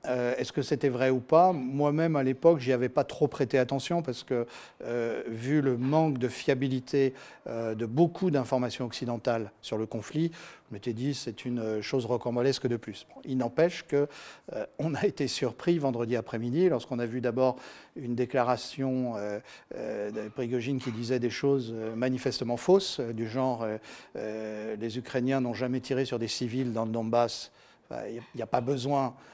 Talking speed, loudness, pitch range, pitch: 185 wpm, -30 LUFS, 120-140 Hz, 125 Hz